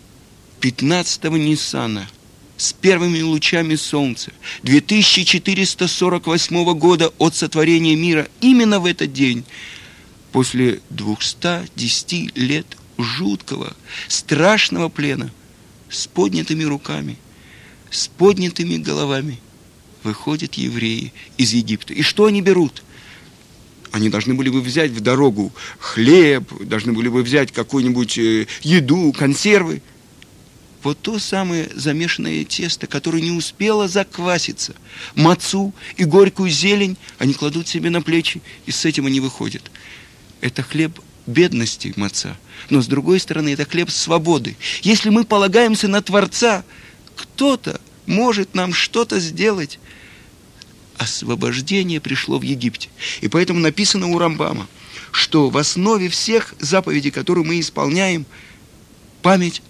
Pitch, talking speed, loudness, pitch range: 160 Hz, 115 wpm, -17 LUFS, 130-180 Hz